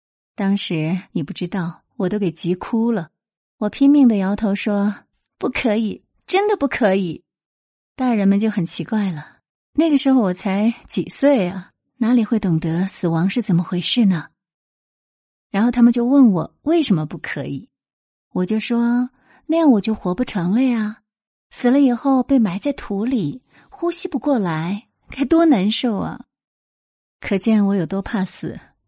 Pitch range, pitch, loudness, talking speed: 185-250 Hz, 215 Hz, -19 LUFS, 225 characters per minute